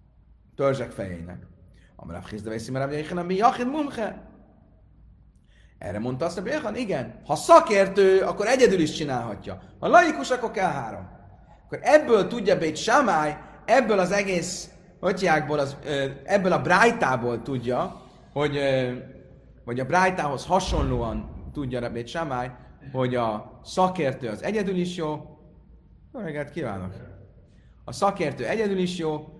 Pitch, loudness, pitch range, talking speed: 150 Hz, -24 LUFS, 125-185 Hz, 115 wpm